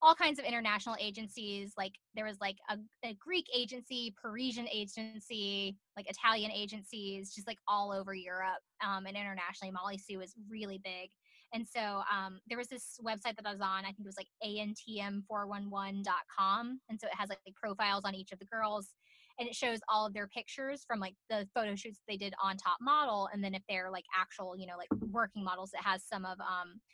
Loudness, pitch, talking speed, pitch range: -38 LUFS, 205 Hz, 205 wpm, 195-225 Hz